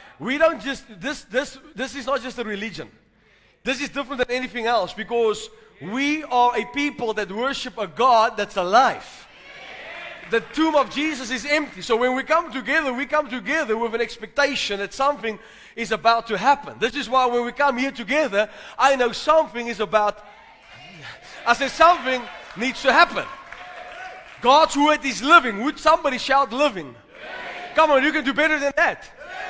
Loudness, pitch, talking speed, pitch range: -21 LUFS, 260 Hz, 175 wpm, 230-290 Hz